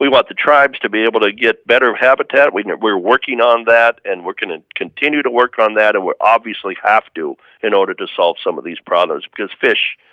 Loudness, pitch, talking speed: -14 LUFS, 135 Hz, 230 wpm